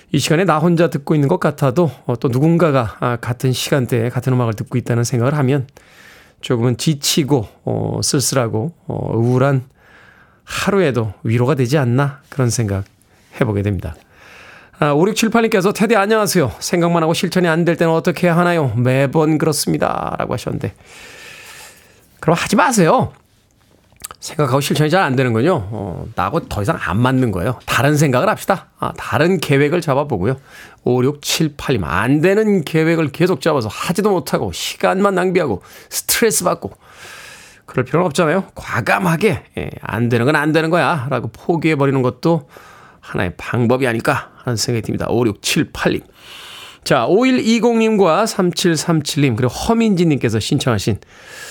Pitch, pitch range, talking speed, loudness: 145 Hz, 125-175 Hz, 315 characters per minute, -16 LUFS